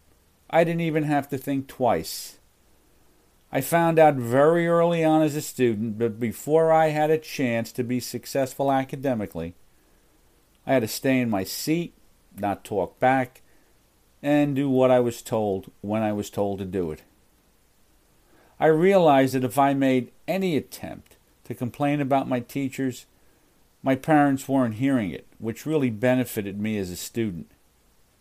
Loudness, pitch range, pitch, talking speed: -24 LUFS, 115-145 Hz, 130 Hz, 155 wpm